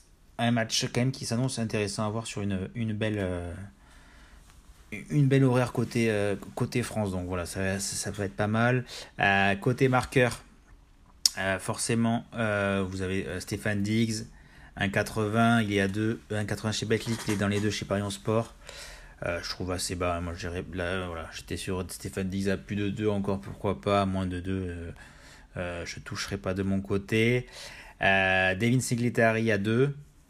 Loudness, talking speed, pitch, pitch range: -28 LUFS, 190 wpm, 100 Hz, 95-115 Hz